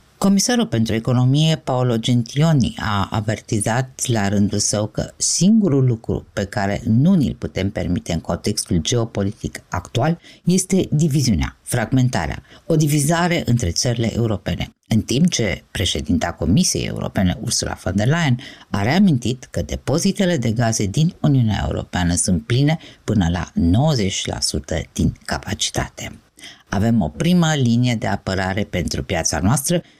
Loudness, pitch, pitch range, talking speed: -19 LUFS, 115 Hz, 100-145 Hz, 130 wpm